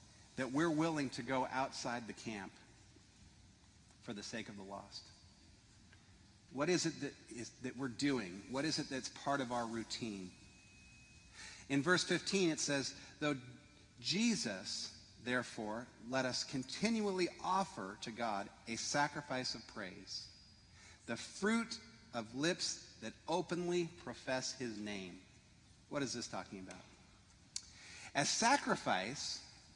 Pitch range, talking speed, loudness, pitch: 100-140 Hz, 130 wpm, -40 LUFS, 115 Hz